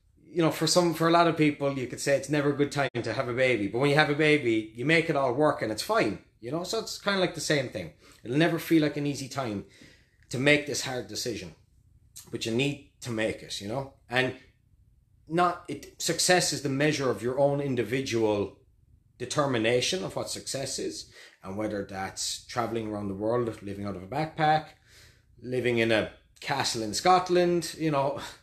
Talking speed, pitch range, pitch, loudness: 215 wpm, 110-155 Hz, 130 Hz, -27 LUFS